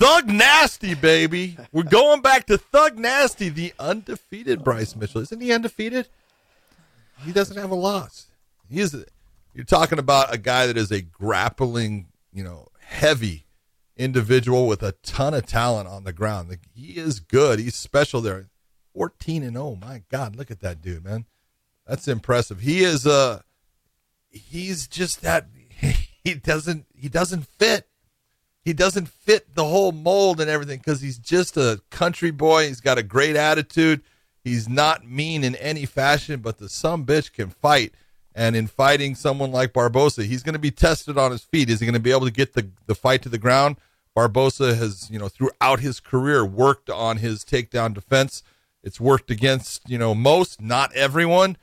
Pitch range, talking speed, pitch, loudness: 115-160 Hz, 180 wpm, 135 Hz, -20 LUFS